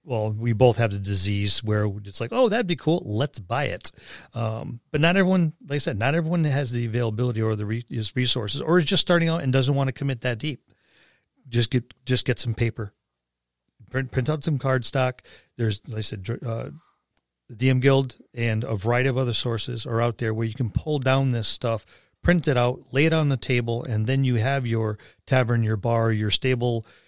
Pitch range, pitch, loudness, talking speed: 115-135 Hz, 125 Hz, -24 LUFS, 215 wpm